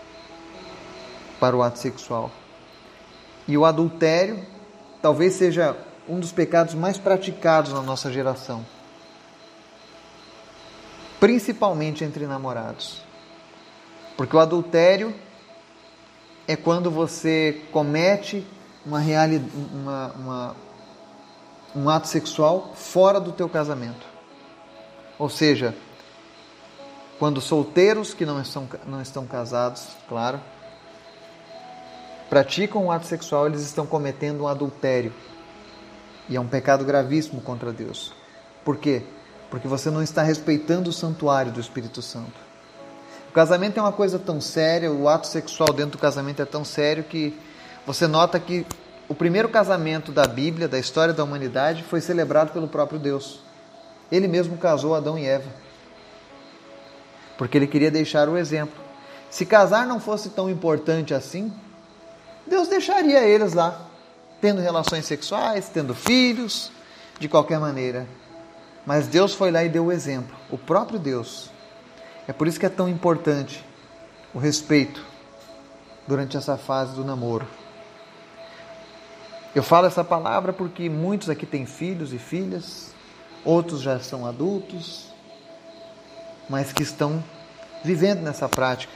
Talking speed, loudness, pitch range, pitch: 125 wpm, -22 LUFS, 135-175 Hz, 155 Hz